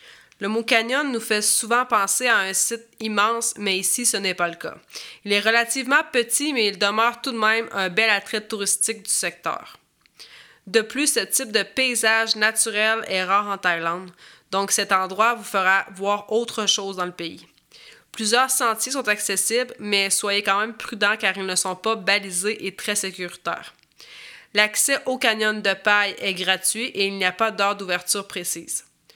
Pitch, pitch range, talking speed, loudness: 210 Hz, 195-230 Hz, 185 wpm, -21 LUFS